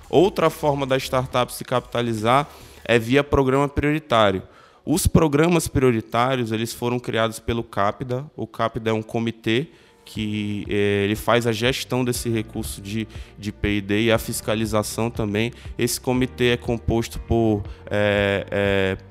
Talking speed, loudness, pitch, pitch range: 140 wpm, -22 LUFS, 115 Hz, 105-125 Hz